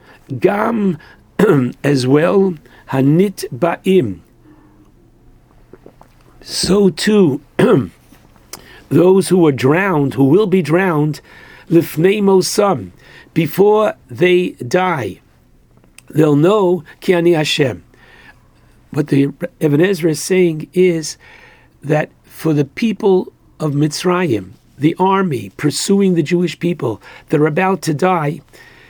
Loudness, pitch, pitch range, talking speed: -15 LUFS, 165 Hz, 145-185 Hz, 100 wpm